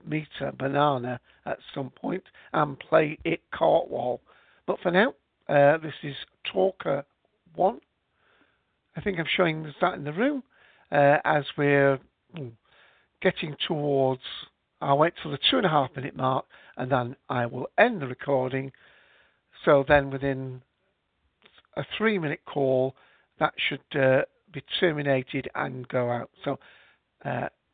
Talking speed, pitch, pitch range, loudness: 140 wpm, 140 Hz, 130-155 Hz, -26 LUFS